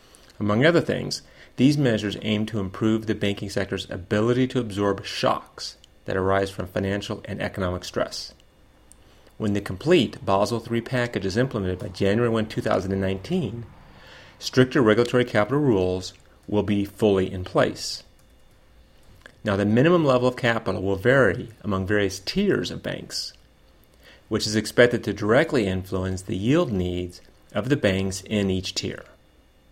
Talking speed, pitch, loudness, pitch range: 145 wpm, 100 Hz, -24 LUFS, 95-115 Hz